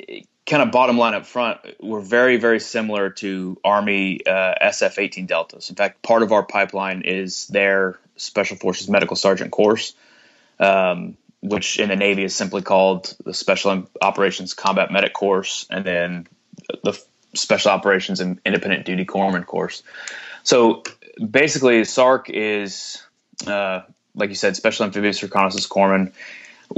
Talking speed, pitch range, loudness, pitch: 145 wpm, 95-105 Hz, -19 LUFS, 100 Hz